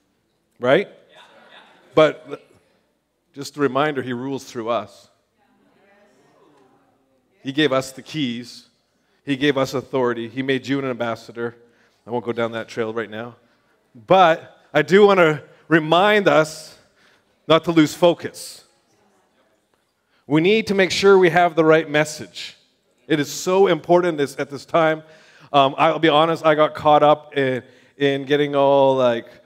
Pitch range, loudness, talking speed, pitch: 125-160 Hz, -18 LUFS, 150 wpm, 140 Hz